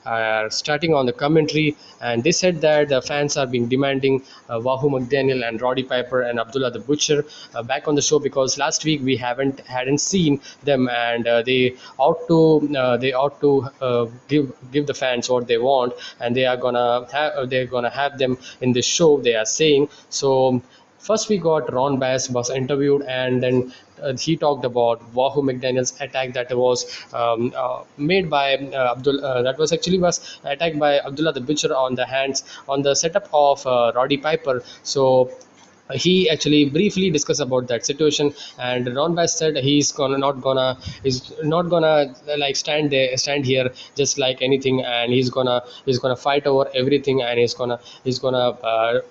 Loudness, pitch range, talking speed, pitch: -20 LUFS, 125-145 Hz, 190 wpm, 135 Hz